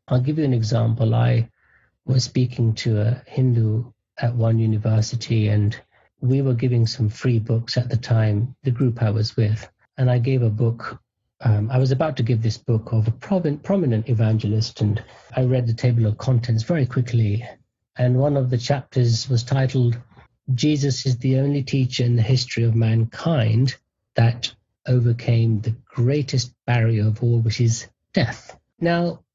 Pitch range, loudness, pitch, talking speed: 115-130 Hz, -21 LUFS, 120 Hz, 170 wpm